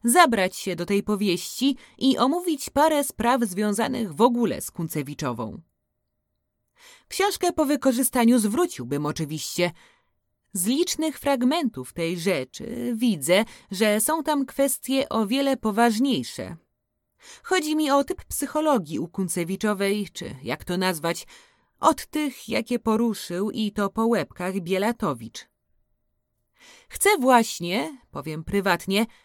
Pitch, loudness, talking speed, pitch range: 225 Hz, -24 LUFS, 115 wpm, 185-275 Hz